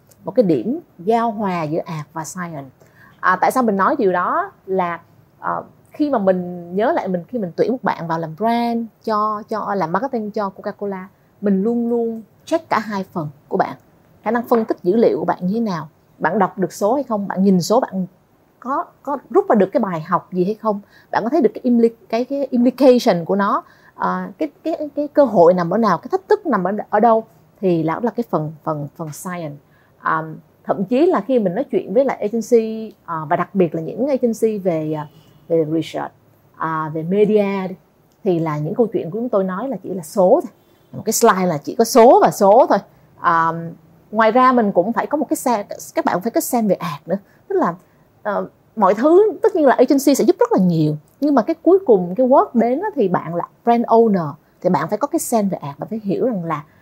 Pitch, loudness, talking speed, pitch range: 200 Hz, -18 LUFS, 240 wpm, 170-235 Hz